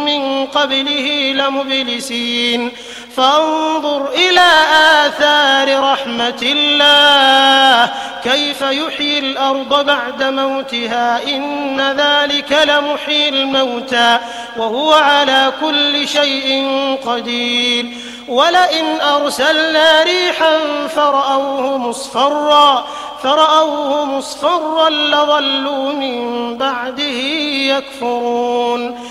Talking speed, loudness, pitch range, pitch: 70 wpm, -13 LUFS, 260-295 Hz, 275 Hz